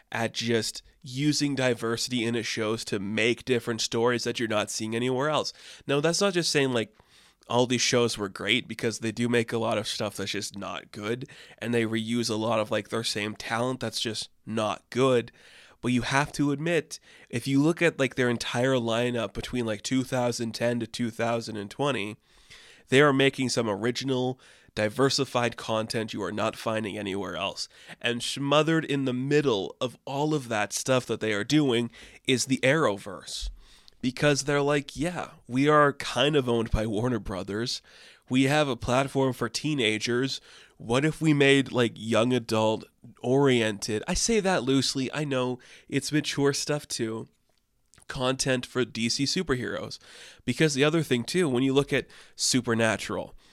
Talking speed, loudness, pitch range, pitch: 170 wpm, -27 LUFS, 115-135 Hz, 120 Hz